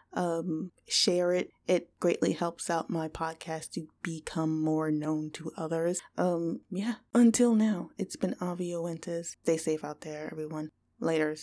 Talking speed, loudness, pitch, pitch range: 145 wpm, -31 LUFS, 165 Hz, 155-180 Hz